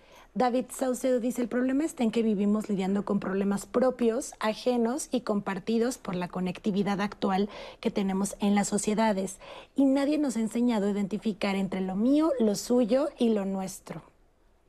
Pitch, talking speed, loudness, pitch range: 220 Hz, 165 wpm, -28 LUFS, 200-250 Hz